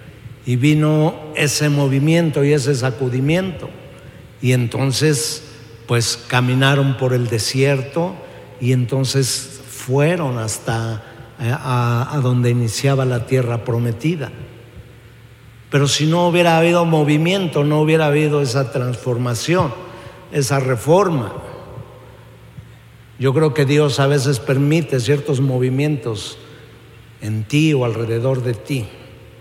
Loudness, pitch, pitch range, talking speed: -17 LUFS, 135 Hz, 120-150 Hz, 110 wpm